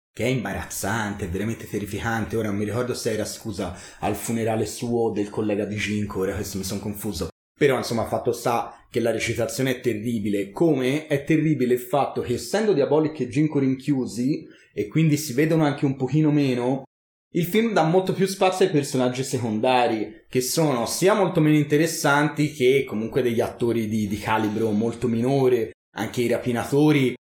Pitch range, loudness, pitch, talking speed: 110-145 Hz, -23 LUFS, 125 Hz, 175 wpm